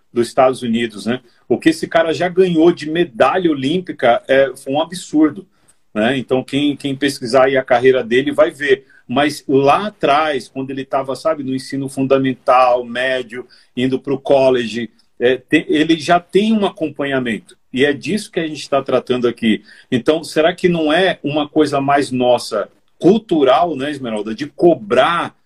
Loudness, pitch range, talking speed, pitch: -16 LUFS, 125-160 Hz, 170 wpm, 135 Hz